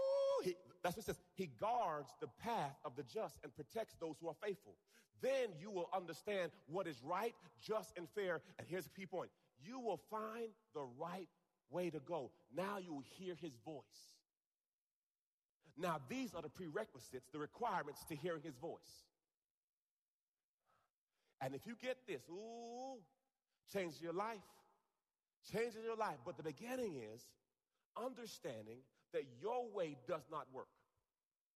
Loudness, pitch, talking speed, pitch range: -47 LUFS, 180 Hz, 150 wpm, 160-225 Hz